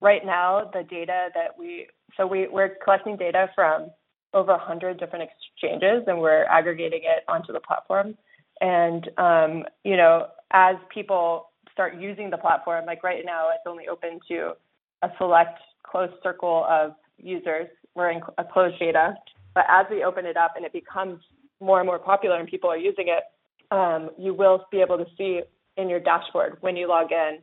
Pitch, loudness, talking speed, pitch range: 180 Hz, -23 LUFS, 180 wpm, 170-190 Hz